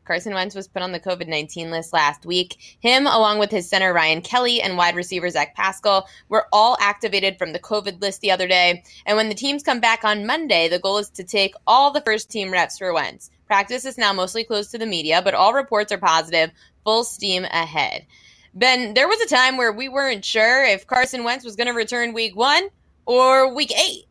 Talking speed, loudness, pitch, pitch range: 220 wpm, -19 LUFS, 210 Hz, 185-245 Hz